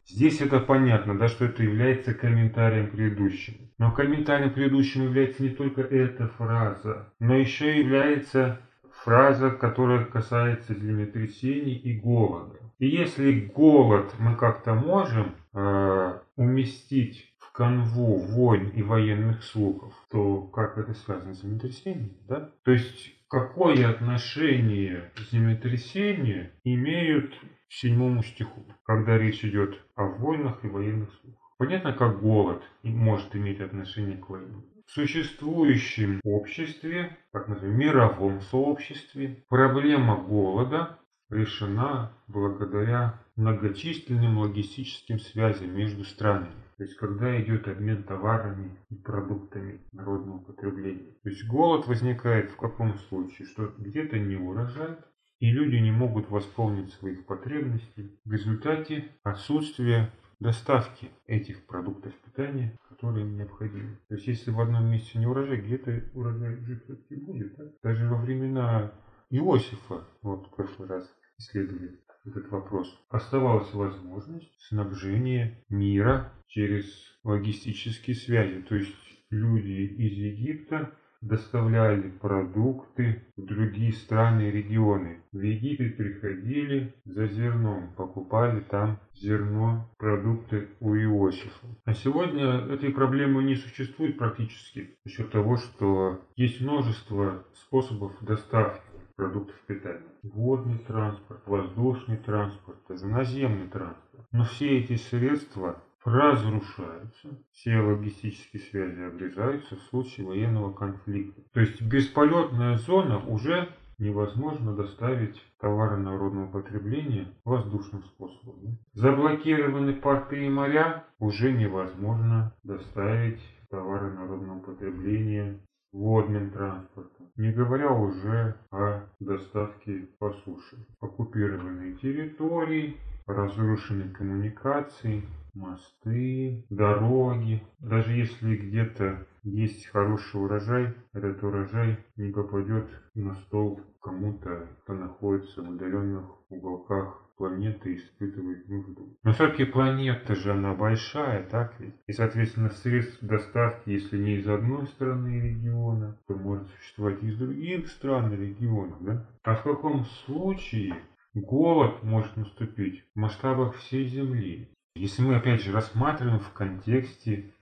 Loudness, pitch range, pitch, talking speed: -27 LUFS, 100-130 Hz, 110 Hz, 115 wpm